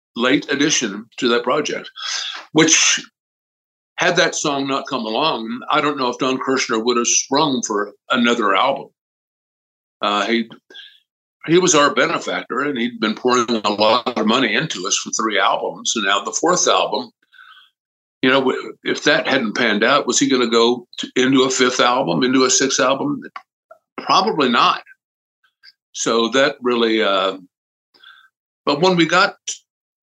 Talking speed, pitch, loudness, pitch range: 160 wpm, 125 Hz, -17 LUFS, 115-145 Hz